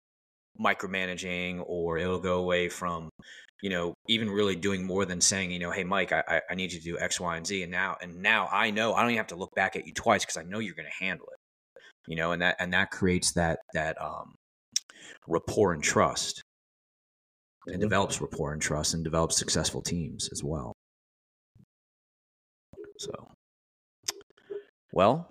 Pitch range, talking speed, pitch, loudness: 85-100 Hz, 185 wpm, 90 Hz, -29 LUFS